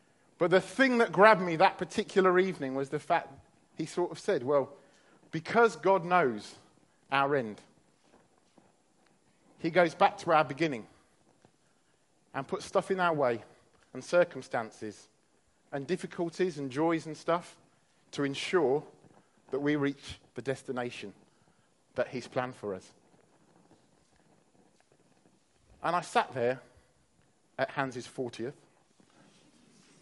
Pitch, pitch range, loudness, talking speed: 155 Hz, 130-180 Hz, -30 LUFS, 120 wpm